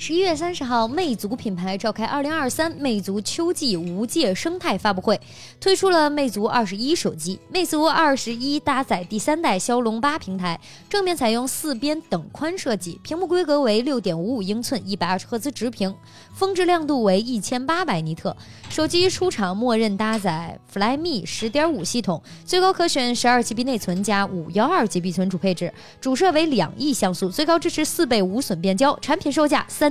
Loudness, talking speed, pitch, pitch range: -22 LUFS, 305 characters per minute, 245 Hz, 200-310 Hz